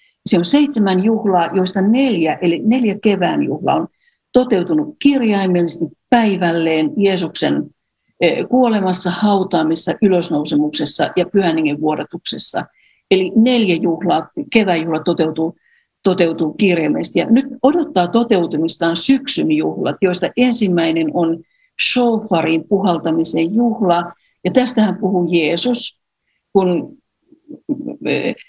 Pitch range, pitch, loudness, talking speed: 170-240 Hz, 190 Hz, -16 LUFS, 95 wpm